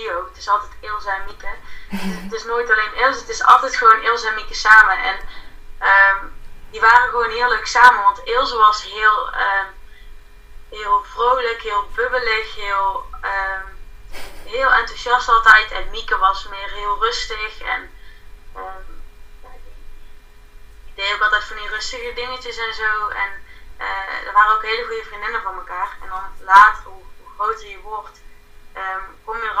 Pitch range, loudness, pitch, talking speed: 195-235 Hz, -17 LUFS, 215 Hz, 170 wpm